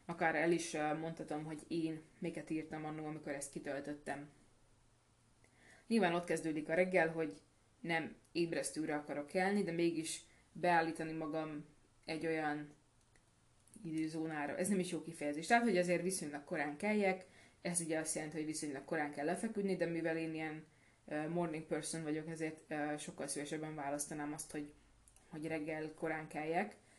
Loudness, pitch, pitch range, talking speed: -40 LUFS, 155 Hz, 150-165 Hz, 145 wpm